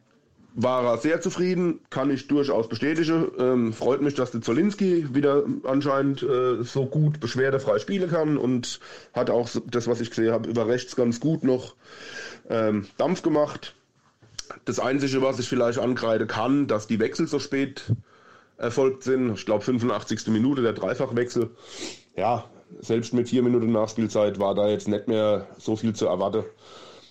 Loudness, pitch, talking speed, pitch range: -25 LUFS, 125 Hz, 160 wpm, 115-140 Hz